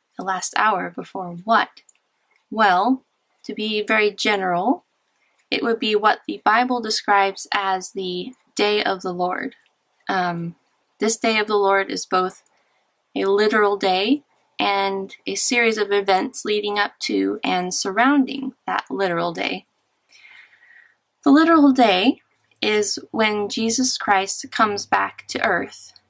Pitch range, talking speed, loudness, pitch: 195-245 Hz, 135 wpm, -20 LUFS, 210 Hz